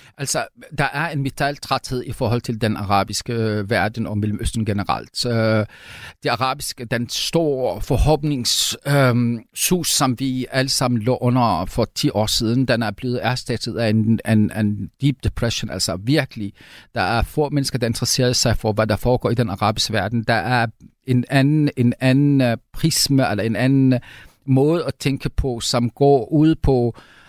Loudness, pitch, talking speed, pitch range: -20 LUFS, 125 Hz, 165 wpm, 110-135 Hz